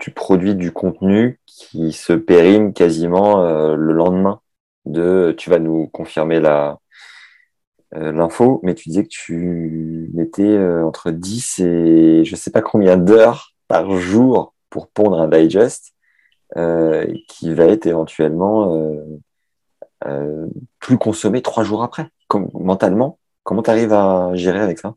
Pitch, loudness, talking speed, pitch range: 90 Hz, -15 LUFS, 150 wpm, 80-105 Hz